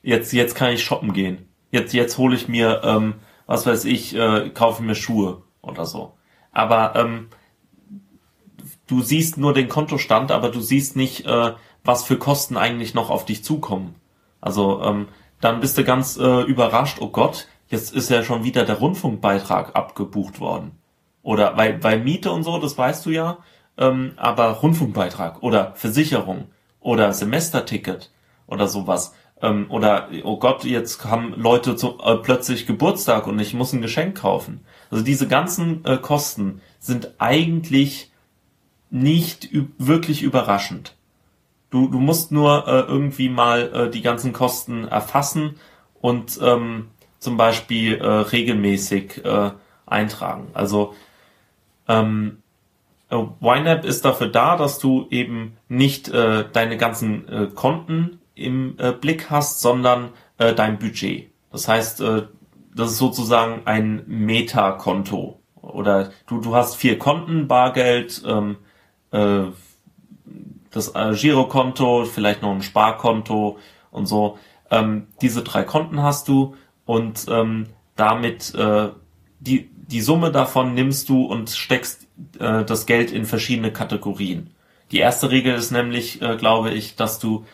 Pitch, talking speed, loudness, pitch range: 120 Hz, 145 wpm, -20 LUFS, 110-130 Hz